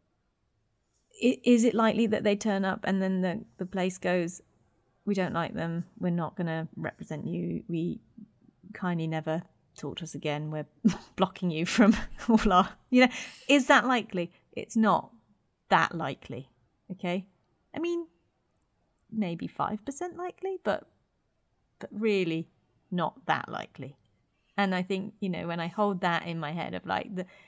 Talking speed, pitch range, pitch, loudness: 160 wpm, 165-215 Hz, 185 Hz, -29 LUFS